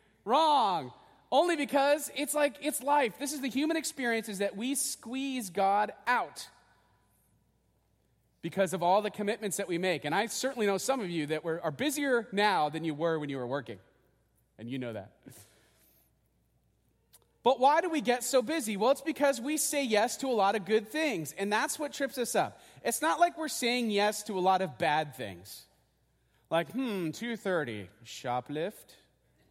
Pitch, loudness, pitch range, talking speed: 215 Hz, -30 LUFS, 165-280 Hz, 185 wpm